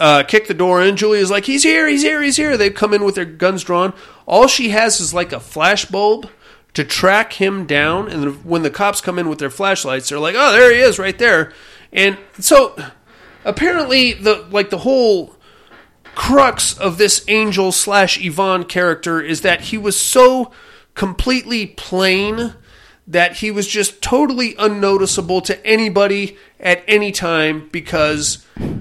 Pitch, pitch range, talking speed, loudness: 200 Hz, 180-220 Hz, 170 wpm, -14 LUFS